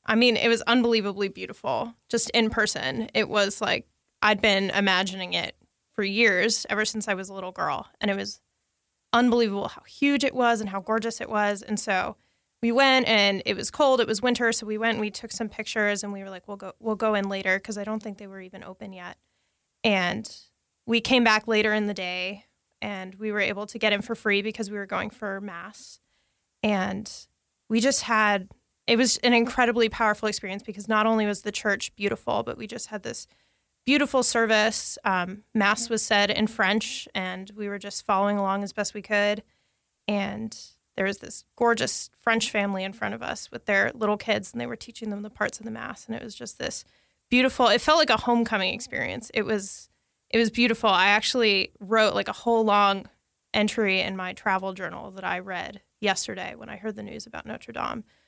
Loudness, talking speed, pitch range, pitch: -25 LUFS, 210 wpm, 200-230 Hz, 215 Hz